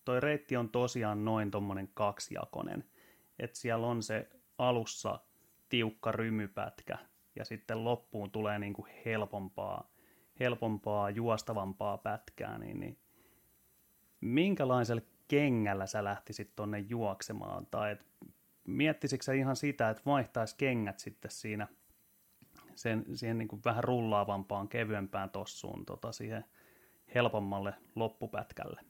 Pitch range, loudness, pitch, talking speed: 105-120 Hz, -36 LUFS, 110 Hz, 110 wpm